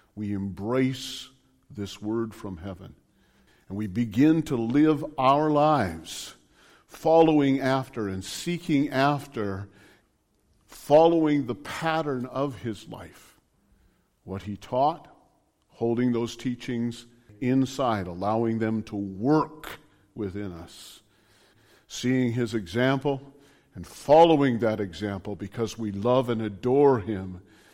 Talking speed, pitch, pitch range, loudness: 110 wpm, 120 Hz, 105-135 Hz, -25 LUFS